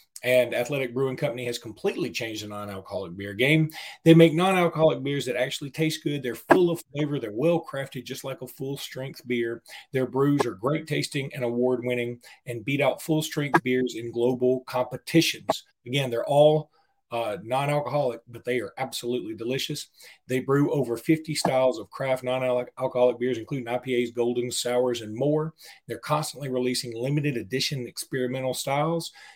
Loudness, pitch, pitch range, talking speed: -26 LUFS, 130 Hz, 125-150 Hz, 165 wpm